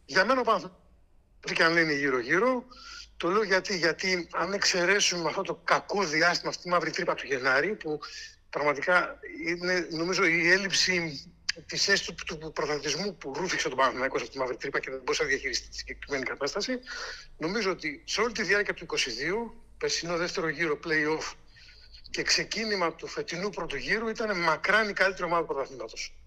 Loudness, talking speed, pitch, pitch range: -28 LUFS, 175 wpm, 185 Hz, 165-220 Hz